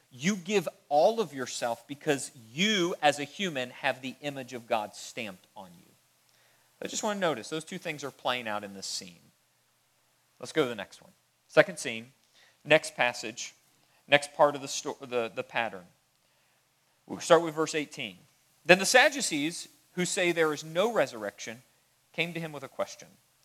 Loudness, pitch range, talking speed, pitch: -29 LUFS, 125-165 Hz, 180 wpm, 145 Hz